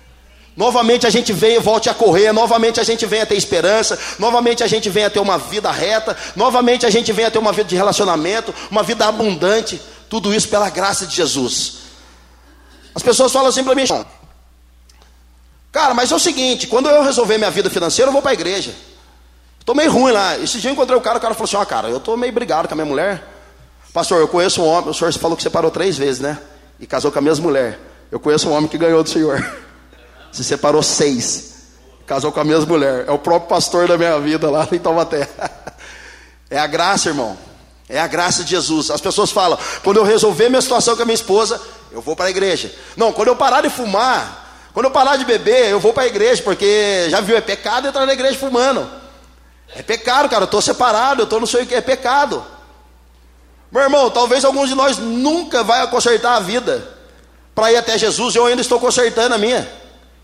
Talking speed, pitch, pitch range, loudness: 220 wpm, 215 Hz, 155-240 Hz, -15 LUFS